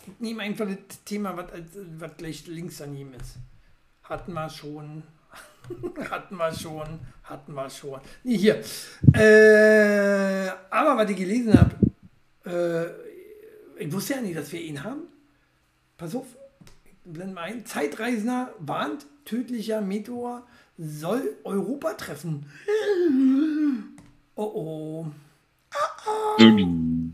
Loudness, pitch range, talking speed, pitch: -23 LUFS, 155-245 Hz, 120 wpm, 195 Hz